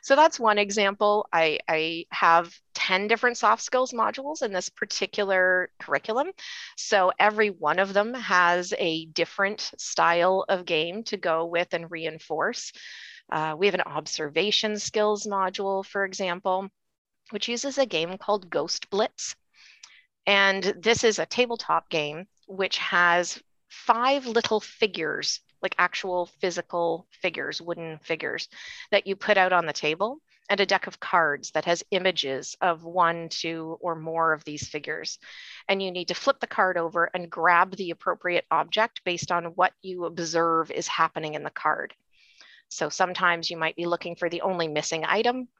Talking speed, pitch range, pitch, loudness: 160 wpm, 170-210 Hz, 185 Hz, -25 LUFS